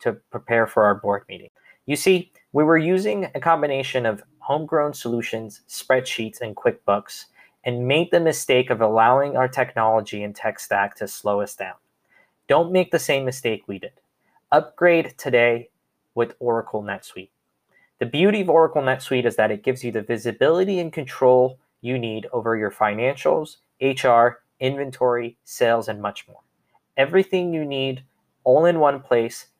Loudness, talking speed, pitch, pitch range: -21 LUFS, 160 wpm, 130 Hz, 115-150 Hz